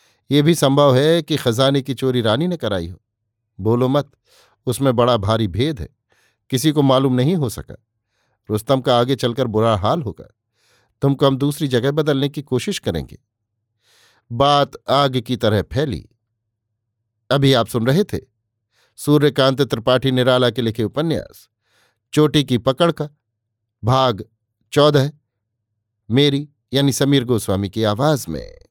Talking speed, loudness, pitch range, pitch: 145 wpm, -18 LUFS, 110-140 Hz, 125 Hz